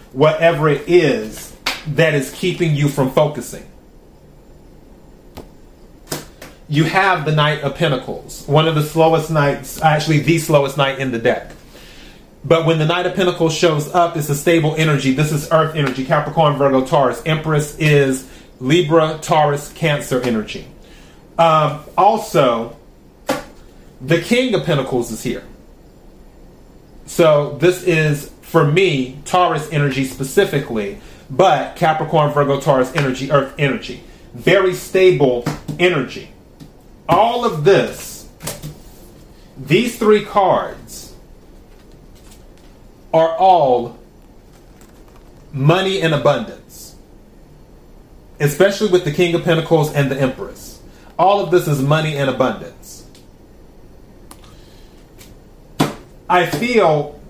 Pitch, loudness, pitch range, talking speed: 155 Hz, -16 LUFS, 140-170 Hz, 110 wpm